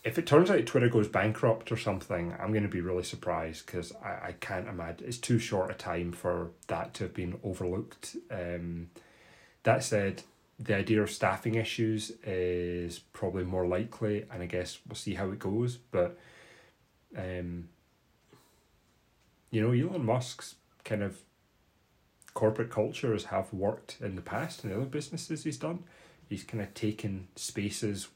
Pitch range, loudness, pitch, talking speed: 90-115 Hz, -33 LUFS, 105 Hz, 165 wpm